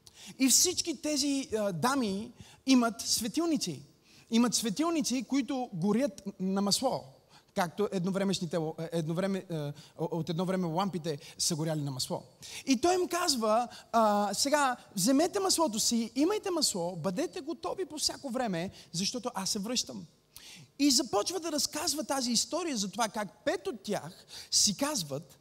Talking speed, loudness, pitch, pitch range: 140 wpm, -30 LUFS, 225 Hz, 185-285 Hz